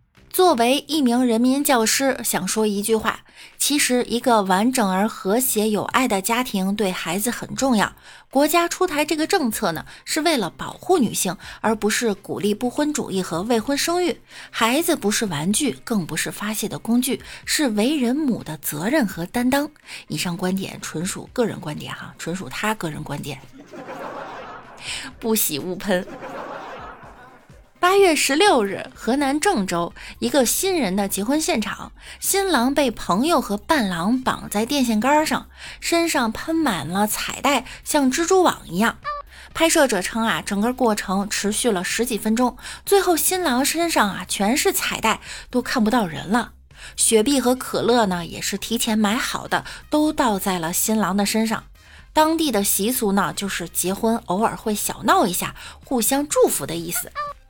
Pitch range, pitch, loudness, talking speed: 200-285 Hz, 230 Hz, -21 LUFS, 245 characters per minute